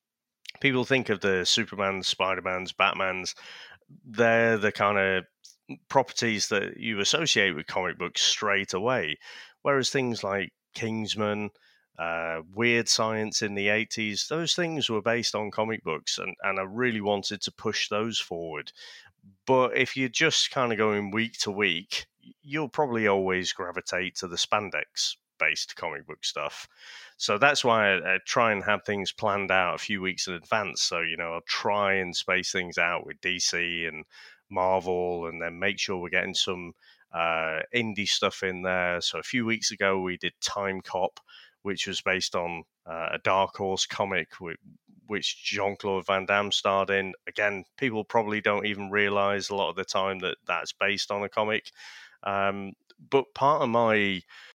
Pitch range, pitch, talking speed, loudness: 95-110 Hz, 100 Hz, 170 wpm, -27 LUFS